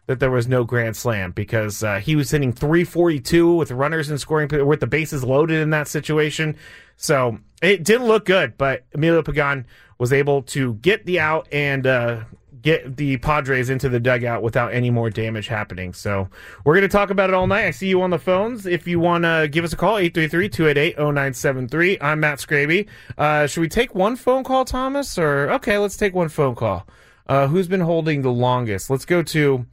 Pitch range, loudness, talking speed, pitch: 125-175 Hz, -19 LUFS, 205 wpm, 150 Hz